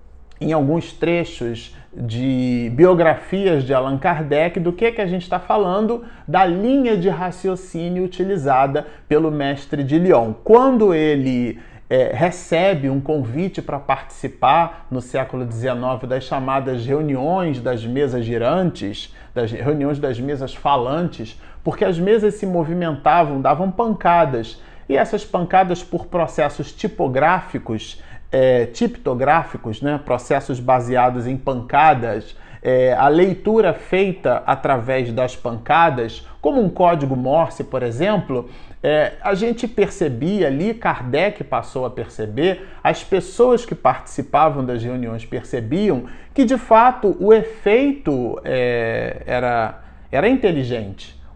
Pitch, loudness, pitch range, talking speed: 150 Hz, -19 LUFS, 125-185 Hz, 125 wpm